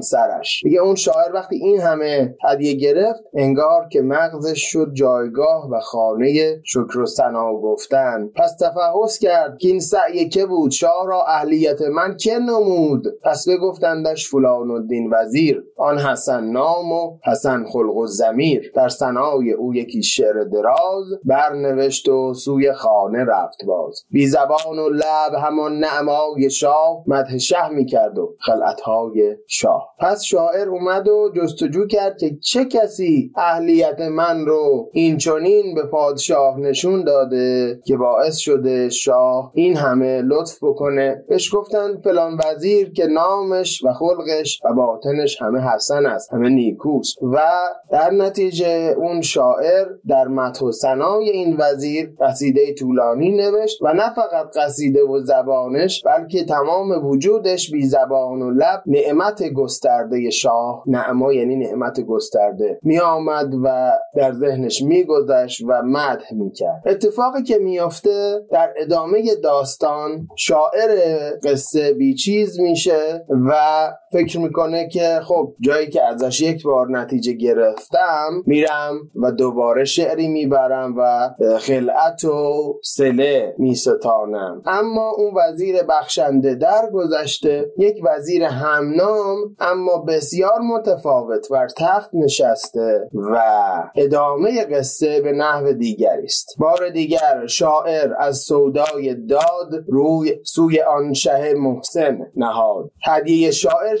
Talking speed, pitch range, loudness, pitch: 130 wpm, 135-195 Hz, -17 LUFS, 155 Hz